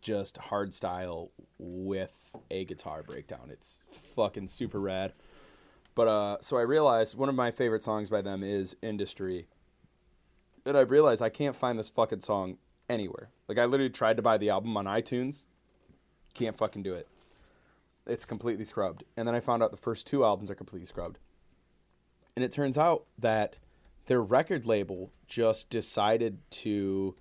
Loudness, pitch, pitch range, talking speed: -30 LUFS, 110 Hz, 95-115 Hz, 165 wpm